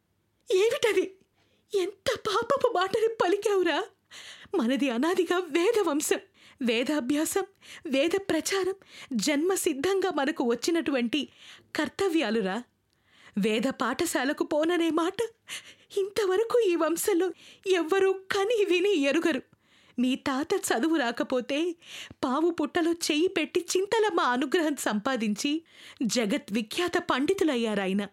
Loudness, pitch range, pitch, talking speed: -27 LUFS, 280-380 Hz, 335 Hz, 85 wpm